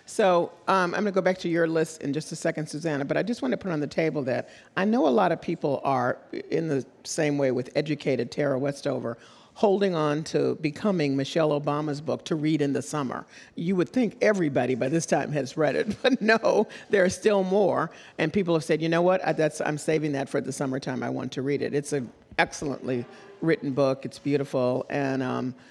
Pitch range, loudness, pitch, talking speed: 140-175 Hz, -26 LUFS, 150 Hz, 225 wpm